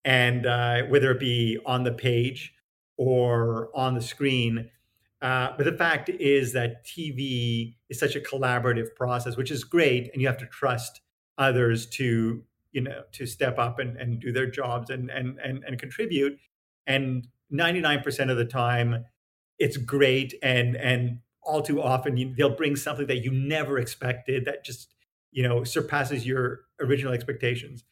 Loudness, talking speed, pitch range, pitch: -26 LUFS, 165 wpm, 120-140 Hz, 130 Hz